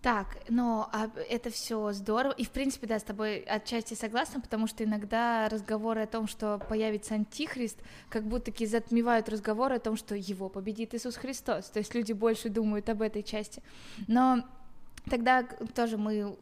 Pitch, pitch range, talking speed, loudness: 225 Hz, 215-240 Hz, 170 wpm, -32 LUFS